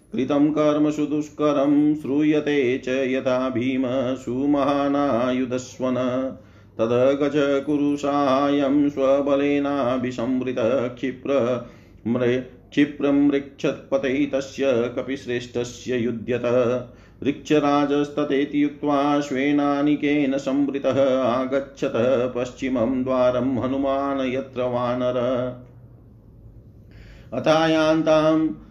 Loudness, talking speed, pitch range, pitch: -22 LUFS, 55 wpm, 125-145 Hz, 135 Hz